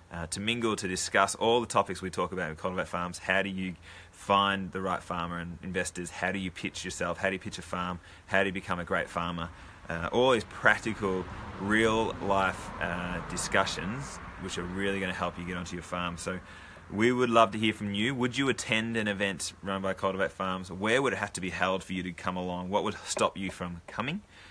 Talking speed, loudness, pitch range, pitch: 230 wpm, -30 LUFS, 90-100 Hz, 95 Hz